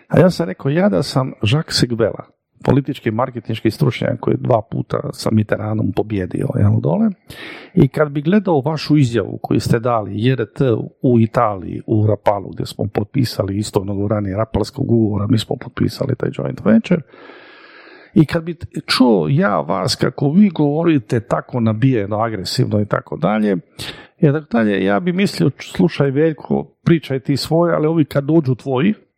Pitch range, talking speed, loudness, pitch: 110-160 Hz, 160 wpm, -17 LUFS, 135 Hz